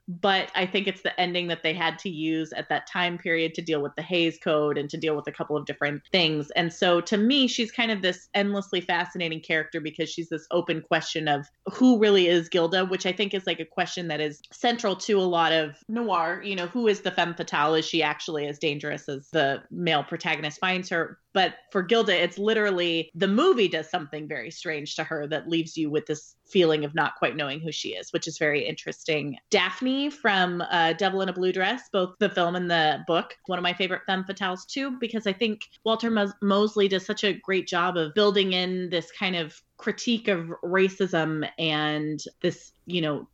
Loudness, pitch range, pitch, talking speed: -26 LUFS, 160-195 Hz, 175 Hz, 220 wpm